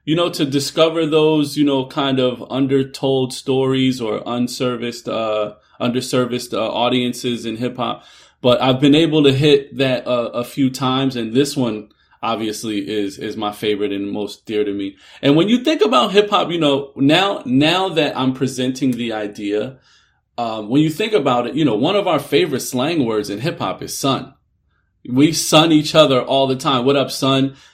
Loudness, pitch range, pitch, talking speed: -17 LUFS, 115-145 Hz, 130 Hz, 195 wpm